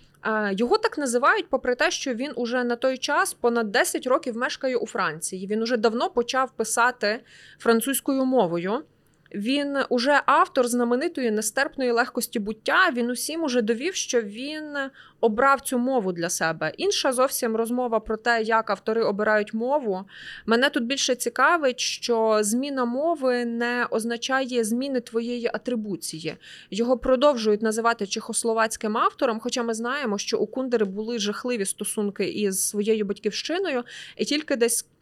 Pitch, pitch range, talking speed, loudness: 240 Hz, 220-265 Hz, 140 wpm, -24 LUFS